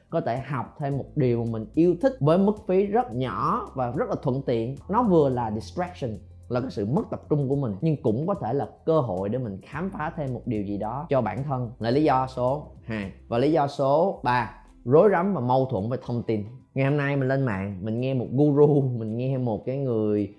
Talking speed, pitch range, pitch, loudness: 245 wpm, 110-145 Hz, 130 Hz, -25 LUFS